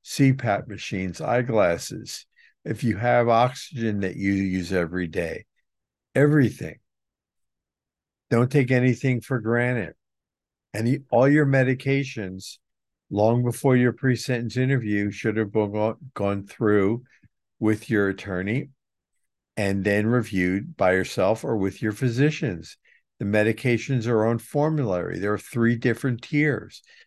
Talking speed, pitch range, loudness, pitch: 120 wpm, 100-130 Hz, -24 LUFS, 115 Hz